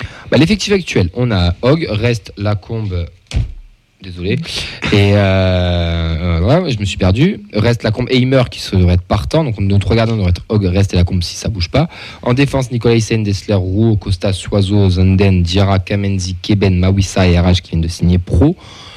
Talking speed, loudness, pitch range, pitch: 195 wpm, -14 LUFS, 90-115 Hz, 100 Hz